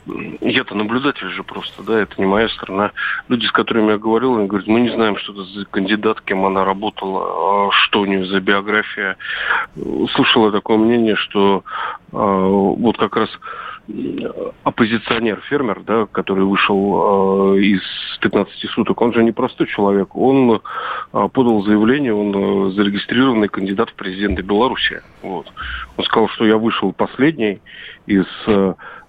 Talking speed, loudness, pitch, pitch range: 155 wpm, -17 LUFS, 100 Hz, 100-110 Hz